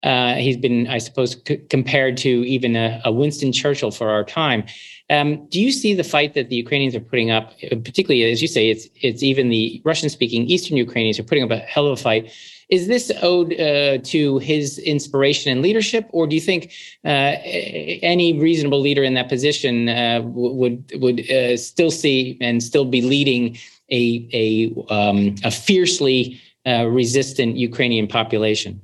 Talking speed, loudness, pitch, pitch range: 180 wpm, -18 LUFS, 130 Hz, 120-145 Hz